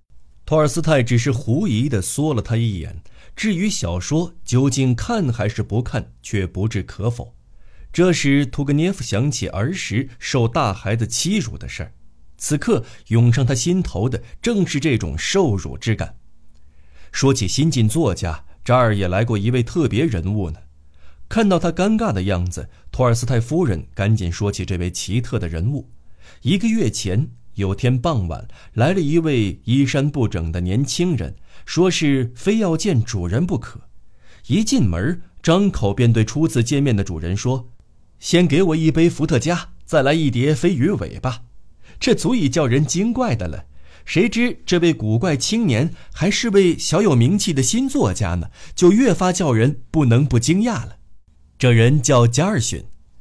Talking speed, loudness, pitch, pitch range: 240 characters per minute, -19 LUFS, 120 Hz, 100-160 Hz